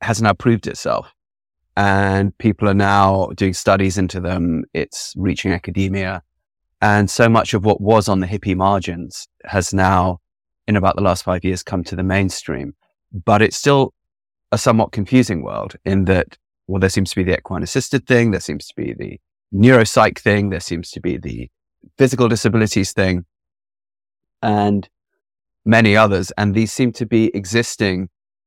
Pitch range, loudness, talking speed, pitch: 95-110 Hz, -17 LUFS, 165 wpm, 100 Hz